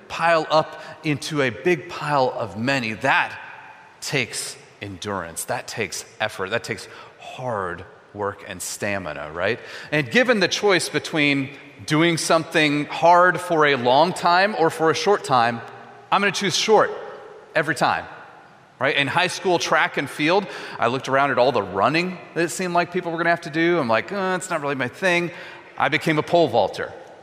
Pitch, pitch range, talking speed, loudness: 160 Hz, 140-175 Hz, 185 wpm, -21 LUFS